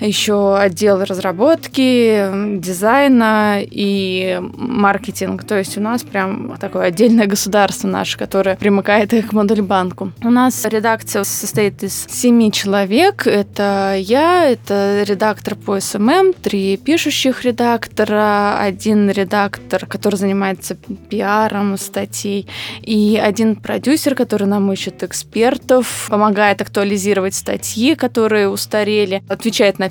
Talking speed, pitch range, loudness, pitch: 110 wpm, 195-225 Hz, -15 LUFS, 205 Hz